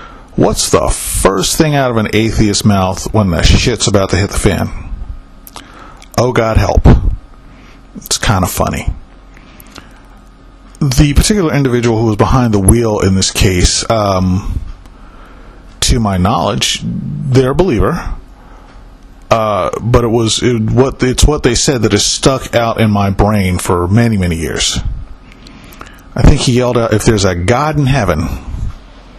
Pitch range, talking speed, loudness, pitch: 95-125 Hz, 150 wpm, -12 LUFS, 110 Hz